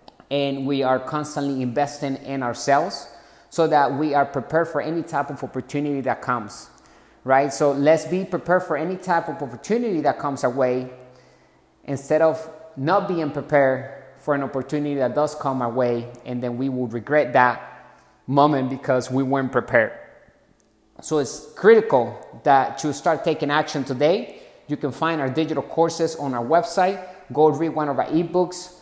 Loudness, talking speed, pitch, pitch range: -22 LUFS, 170 wpm, 145 Hz, 130-160 Hz